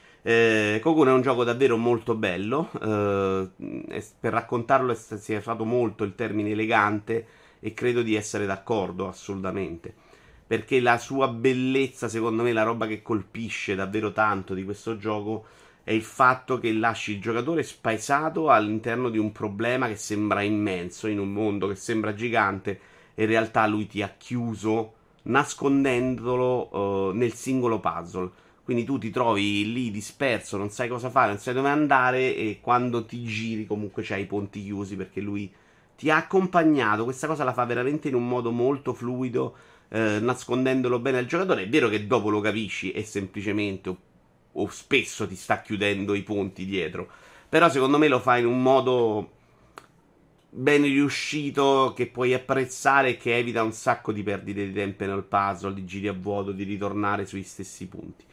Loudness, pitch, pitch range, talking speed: -25 LUFS, 110 Hz, 105-125 Hz, 170 wpm